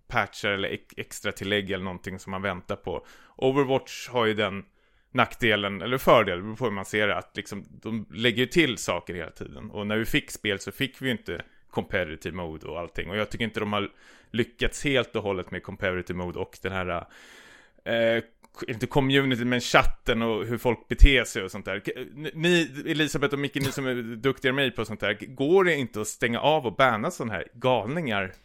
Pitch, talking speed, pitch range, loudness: 115 Hz, 205 wpm, 100-130 Hz, -26 LUFS